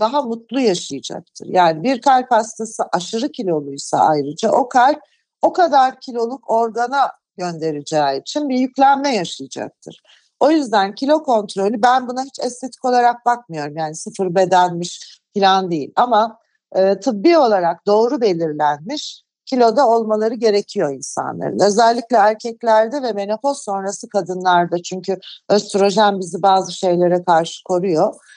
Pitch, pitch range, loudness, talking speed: 215 Hz, 180-250 Hz, -17 LUFS, 125 wpm